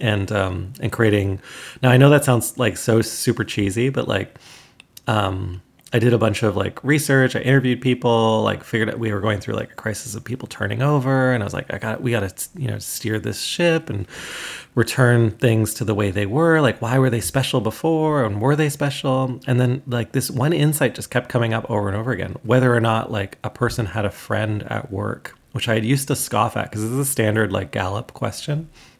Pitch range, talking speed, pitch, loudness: 105-130 Hz, 230 wpm, 115 Hz, -20 LUFS